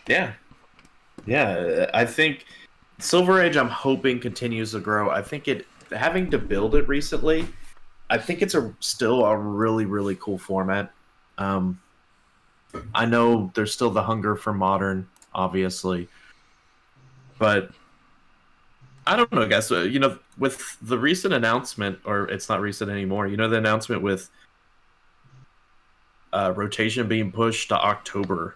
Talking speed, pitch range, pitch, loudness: 145 wpm, 95-120 Hz, 110 Hz, -23 LUFS